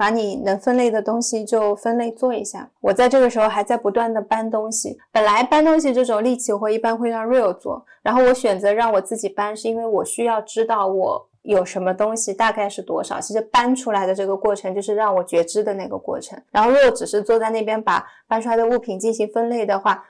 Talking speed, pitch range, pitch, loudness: 365 characters per minute, 205-235 Hz, 220 Hz, -19 LUFS